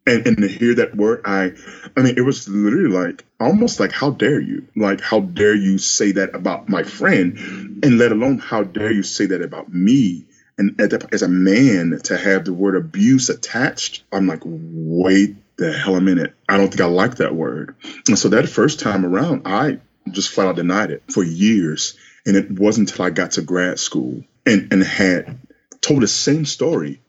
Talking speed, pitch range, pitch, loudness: 200 wpm, 95-105 Hz, 100 Hz, -17 LUFS